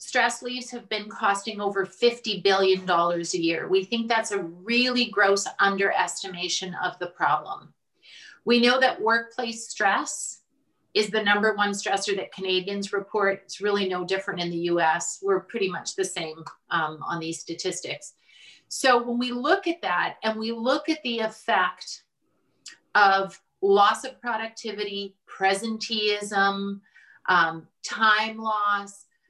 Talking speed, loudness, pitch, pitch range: 140 wpm, -25 LUFS, 205 Hz, 190-230 Hz